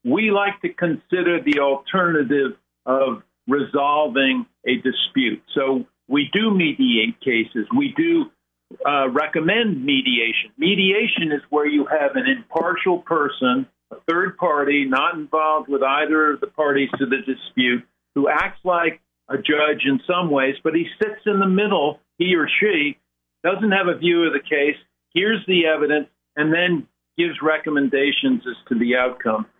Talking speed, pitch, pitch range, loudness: 155 wpm, 155 Hz, 135-185 Hz, -20 LUFS